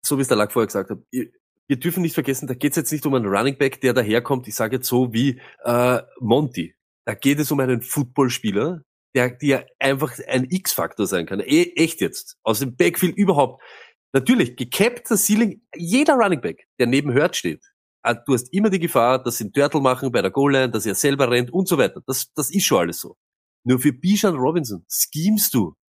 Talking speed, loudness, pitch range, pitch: 215 wpm, -20 LUFS, 125-175 Hz, 140 Hz